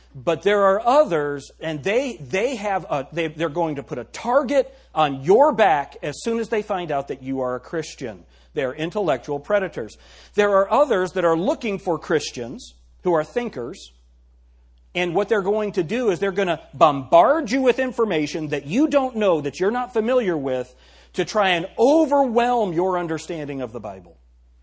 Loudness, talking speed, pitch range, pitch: -21 LUFS, 185 wpm, 140-215 Hz, 175 Hz